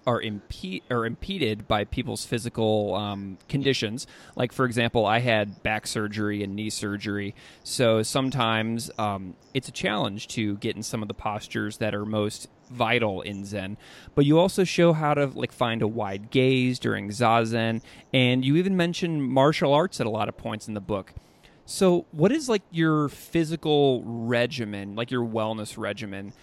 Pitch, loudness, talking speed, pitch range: 115 Hz, -26 LUFS, 175 wpm, 105-130 Hz